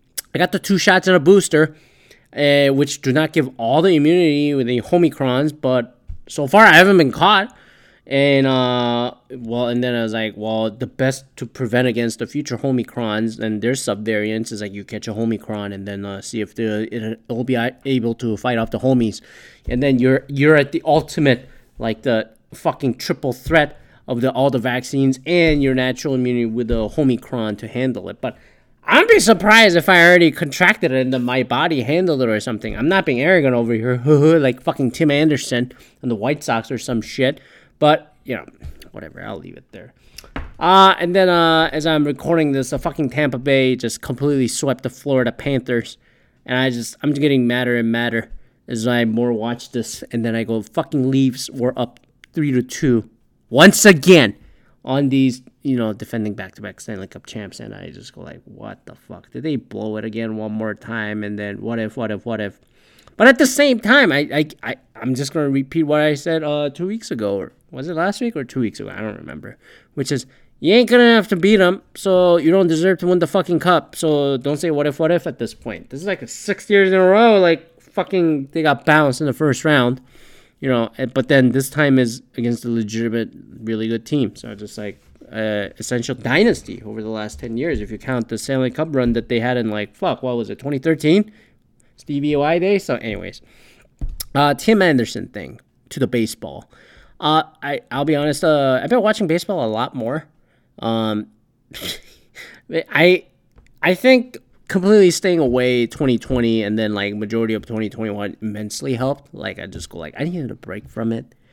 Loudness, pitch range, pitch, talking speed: -17 LUFS, 115-155 Hz, 130 Hz, 210 wpm